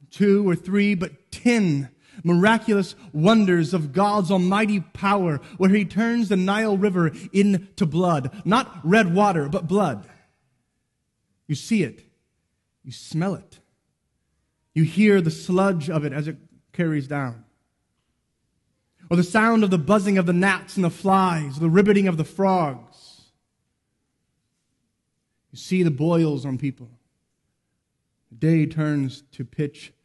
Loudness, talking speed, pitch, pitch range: -21 LUFS, 135 wpm, 175 Hz, 150-200 Hz